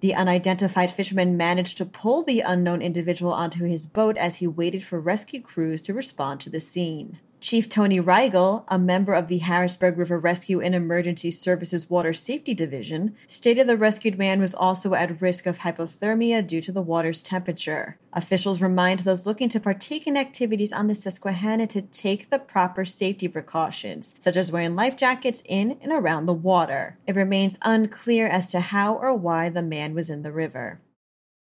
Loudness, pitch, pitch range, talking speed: -24 LUFS, 185 Hz, 175-210 Hz, 180 wpm